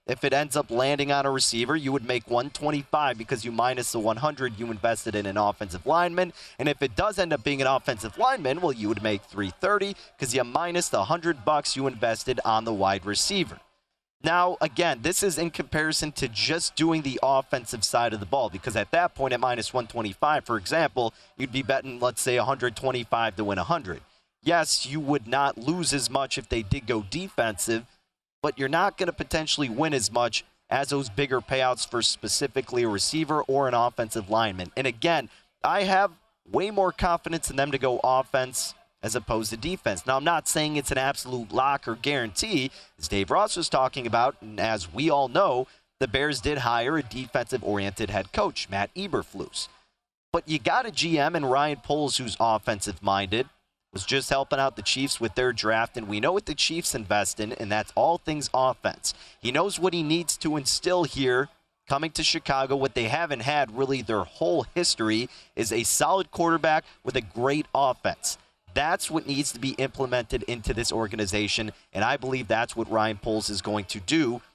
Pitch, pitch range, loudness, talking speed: 135 Hz, 115-155 Hz, -26 LUFS, 195 wpm